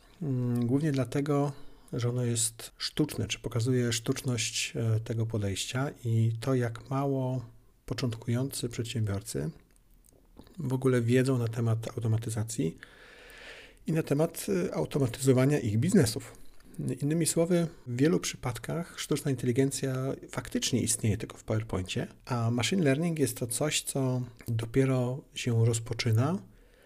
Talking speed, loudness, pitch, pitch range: 115 wpm, -30 LUFS, 125 Hz, 115-140 Hz